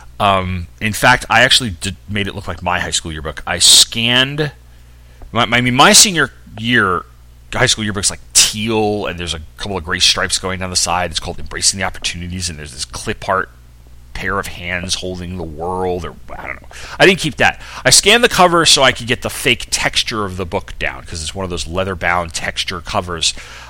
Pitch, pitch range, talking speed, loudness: 95 Hz, 85-110 Hz, 220 wpm, -14 LUFS